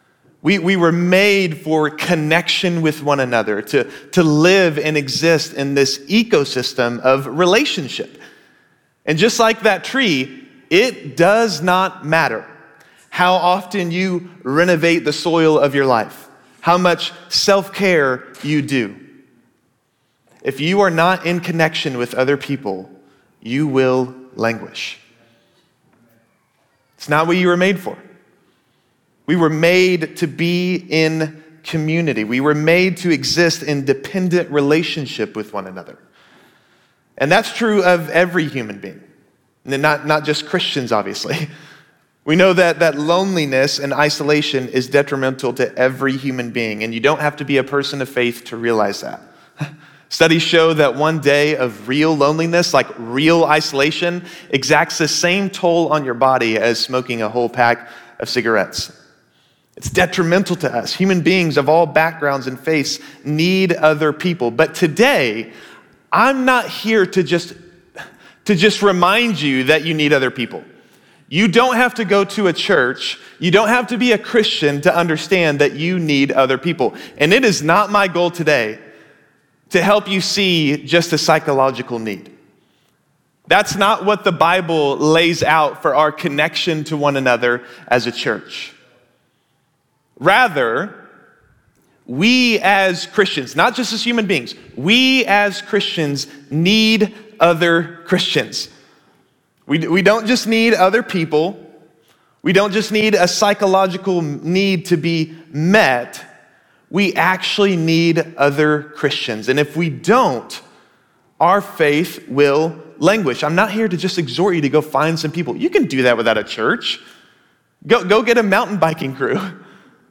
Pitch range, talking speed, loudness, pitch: 140-185 Hz, 145 wpm, -16 LUFS, 160 Hz